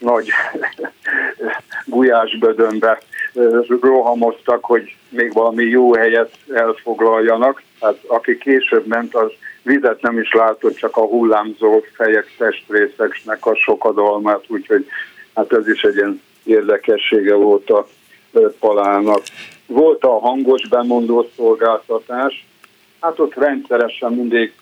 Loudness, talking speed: -15 LUFS, 105 wpm